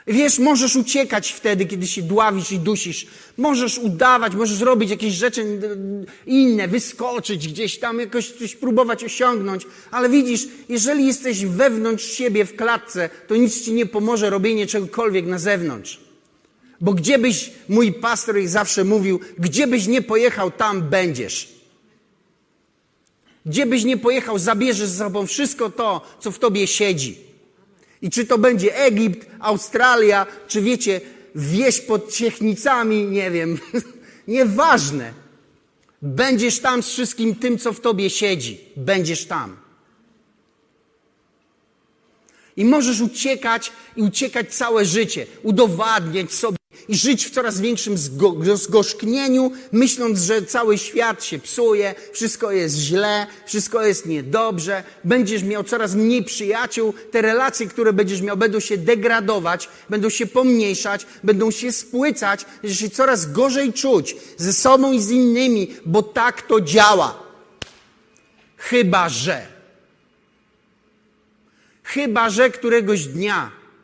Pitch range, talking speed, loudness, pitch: 200-245 Hz, 130 wpm, -19 LUFS, 220 Hz